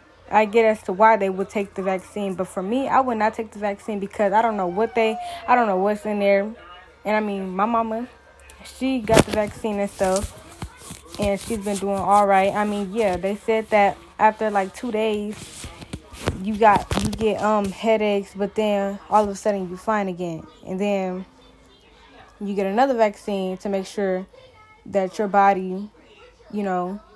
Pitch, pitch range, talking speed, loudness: 205 Hz, 195-220 Hz, 190 wpm, -22 LUFS